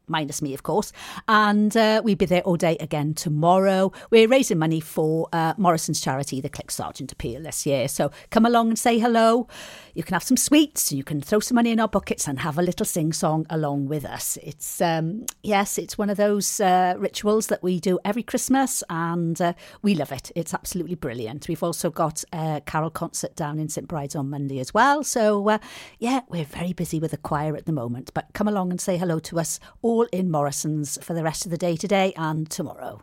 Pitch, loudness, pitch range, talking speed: 175 Hz, -23 LUFS, 155-205 Hz, 220 wpm